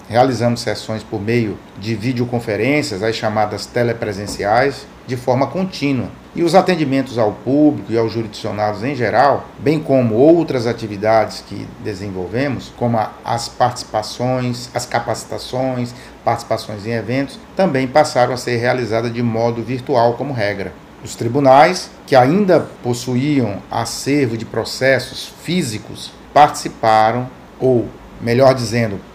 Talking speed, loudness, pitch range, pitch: 120 wpm, -17 LUFS, 110-130 Hz, 120 Hz